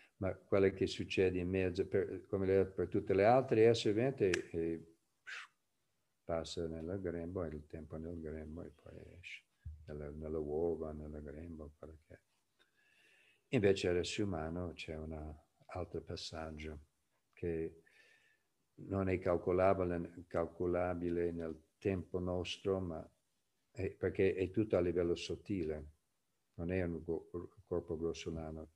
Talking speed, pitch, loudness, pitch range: 125 wpm, 85 Hz, -38 LUFS, 80-90 Hz